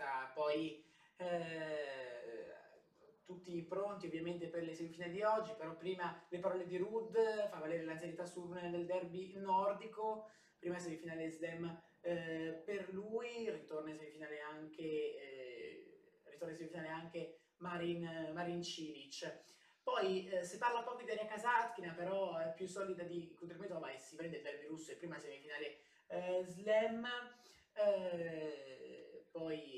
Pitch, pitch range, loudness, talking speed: 175 Hz, 160-200 Hz, -43 LUFS, 135 wpm